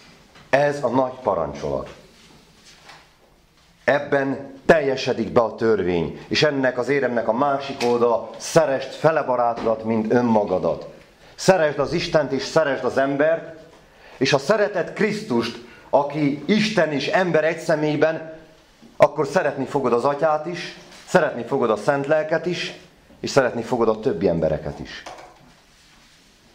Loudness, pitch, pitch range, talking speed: -21 LUFS, 145 Hz, 120-160 Hz, 130 wpm